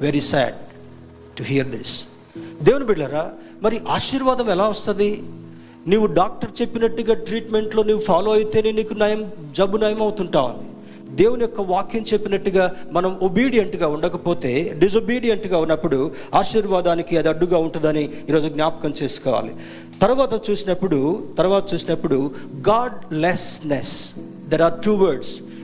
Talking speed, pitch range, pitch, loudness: 115 wpm, 155-215 Hz, 185 Hz, -20 LUFS